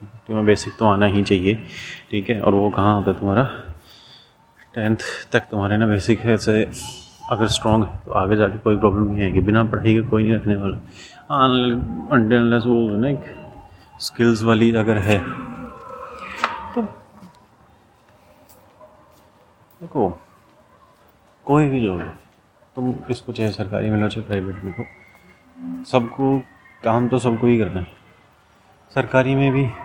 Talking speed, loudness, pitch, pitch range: 140 wpm, -20 LUFS, 110 Hz, 105-125 Hz